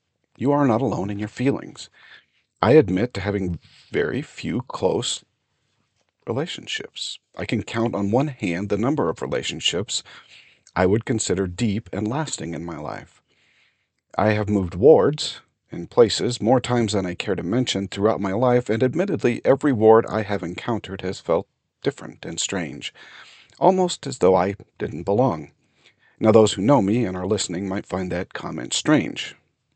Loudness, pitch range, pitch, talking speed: -22 LUFS, 100-125 Hz, 110 Hz, 165 wpm